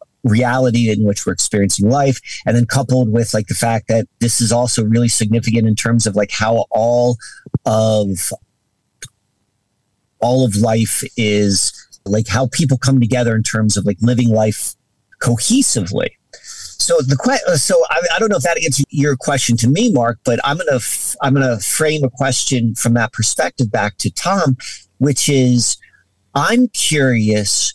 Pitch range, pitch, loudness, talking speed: 110-130 Hz, 120 Hz, -15 LUFS, 165 wpm